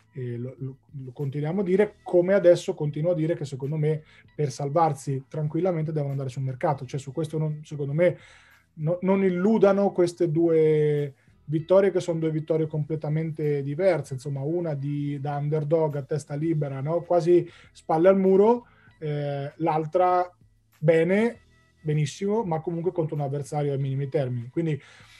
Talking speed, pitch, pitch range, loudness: 155 wpm, 155 Hz, 145-175 Hz, -25 LUFS